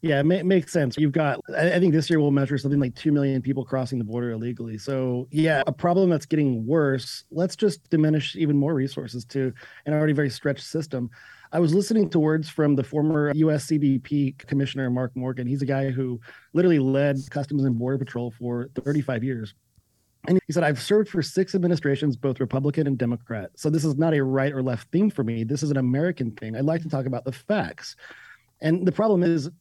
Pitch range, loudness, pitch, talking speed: 130-160 Hz, -24 LUFS, 140 Hz, 215 wpm